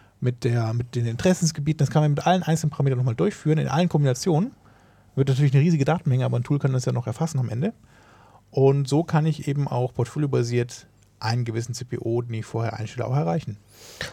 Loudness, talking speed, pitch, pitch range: -24 LUFS, 205 wpm, 135 Hz, 120-155 Hz